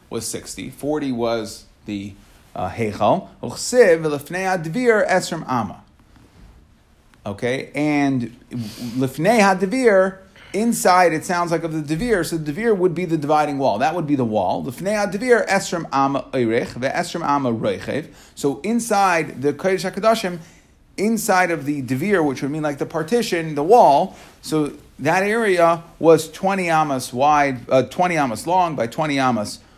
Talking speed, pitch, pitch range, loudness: 120 wpm, 155 Hz, 130-185 Hz, -19 LUFS